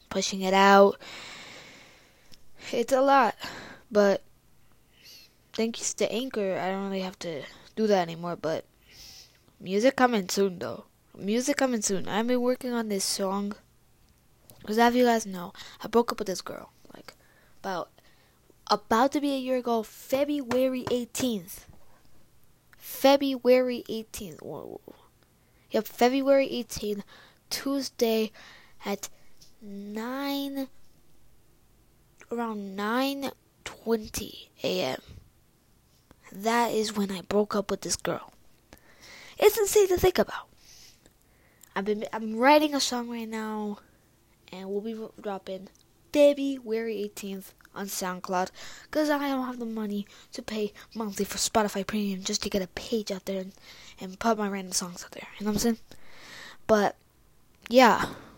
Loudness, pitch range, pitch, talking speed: -27 LUFS, 200-255 Hz, 220 Hz, 135 wpm